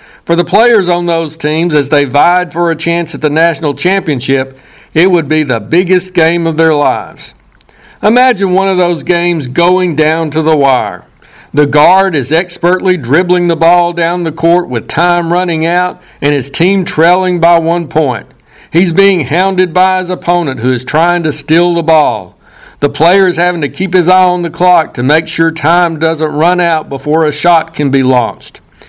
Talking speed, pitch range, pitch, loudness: 195 wpm, 155-180 Hz, 170 Hz, -10 LUFS